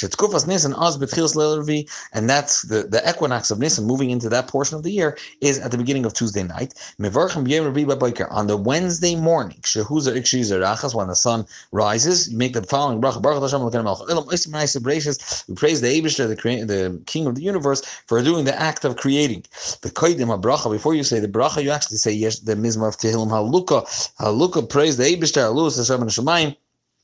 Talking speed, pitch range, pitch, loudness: 155 wpm, 115-155 Hz, 135 Hz, -20 LUFS